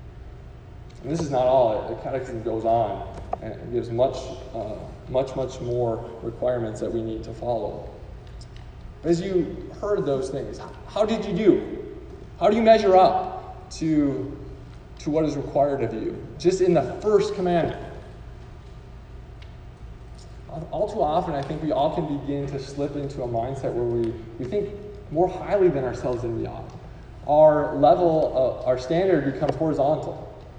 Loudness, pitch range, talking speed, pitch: -24 LUFS, 115-165 Hz, 155 wpm, 135 Hz